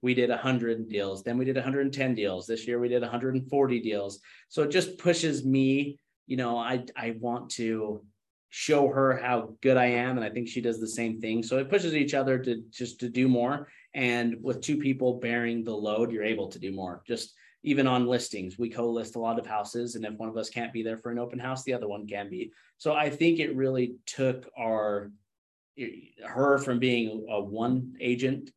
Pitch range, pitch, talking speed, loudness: 115-130 Hz, 120 Hz, 215 wpm, -29 LUFS